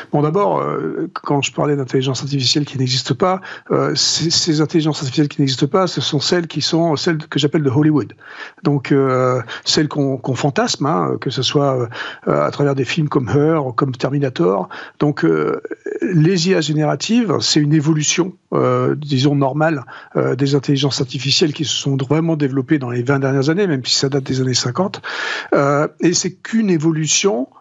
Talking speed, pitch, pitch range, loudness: 185 wpm, 150 Hz, 135-165 Hz, -17 LUFS